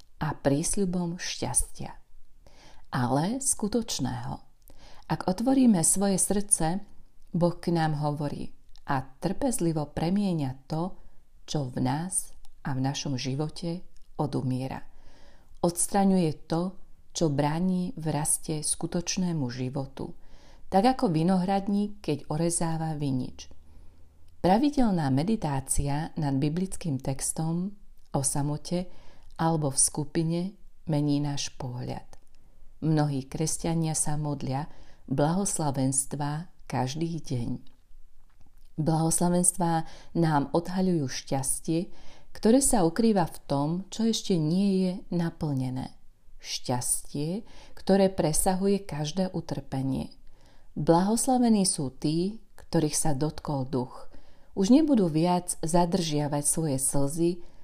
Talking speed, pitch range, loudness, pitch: 95 wpm, 140-185 Hz, -28 LUFS, 160 Hz